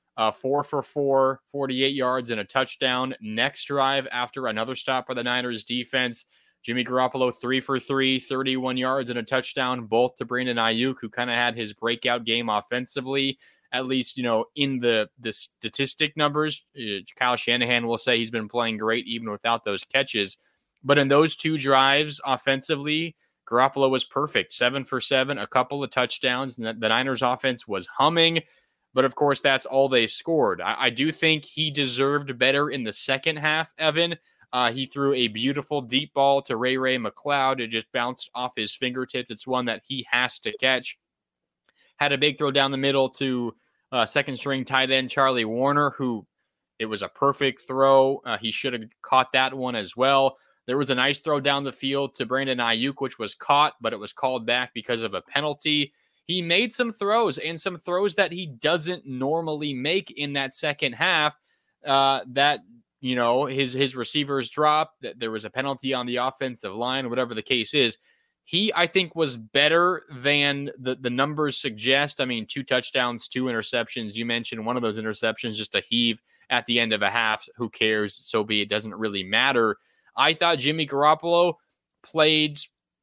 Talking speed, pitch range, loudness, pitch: 190 wpm, 120-140 Hz, -24 LUFS, 130 Hz